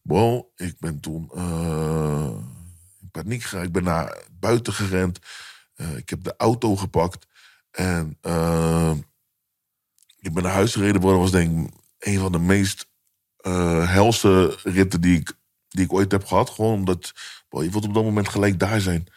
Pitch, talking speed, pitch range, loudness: 95 Hz, 175 wpm, 85-100 Hz, -22 LUFS